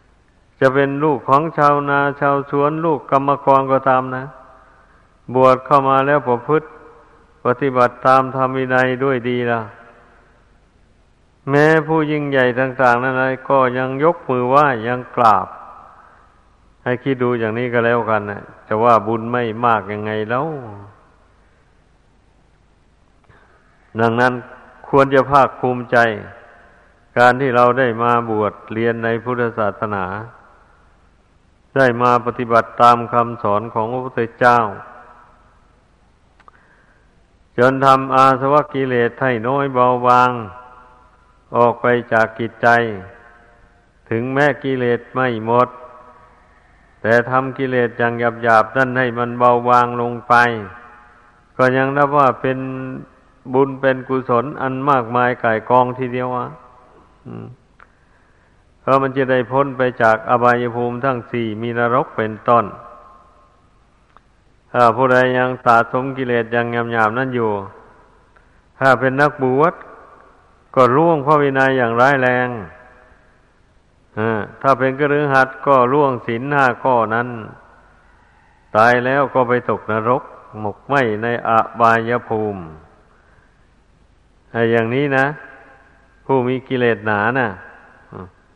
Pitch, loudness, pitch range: 125 Hz, -16 LUFS, 115-130 Hz